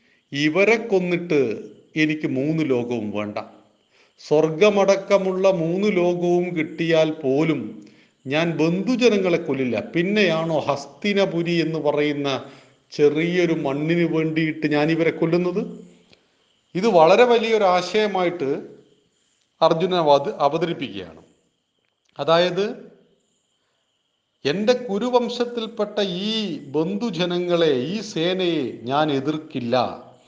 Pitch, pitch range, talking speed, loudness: 165 Hz, 150-195 Hz, 75 wpm, -21 LUFS